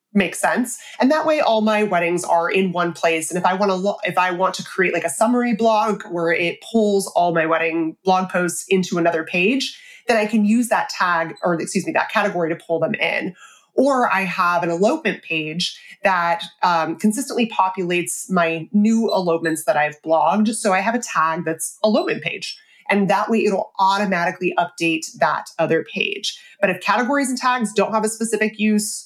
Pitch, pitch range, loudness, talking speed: 190 Hz, 170-220 Hz, -19 LUFS, 200 wpm